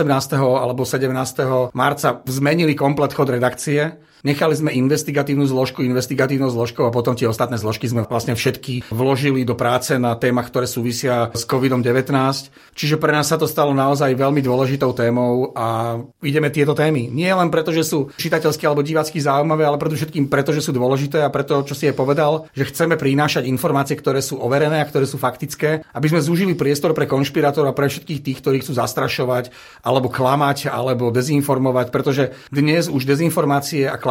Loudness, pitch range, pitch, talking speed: -18 LUFS, 130-150 Hz, 140 Hz, 175 wpm